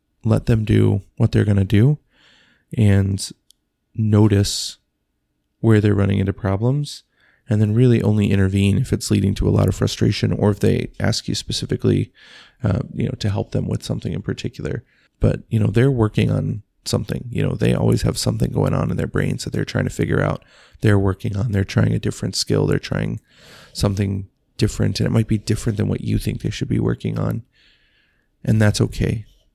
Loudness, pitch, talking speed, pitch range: -20 LUFS, 110 Hz, 195 wpm, 100-115 Hz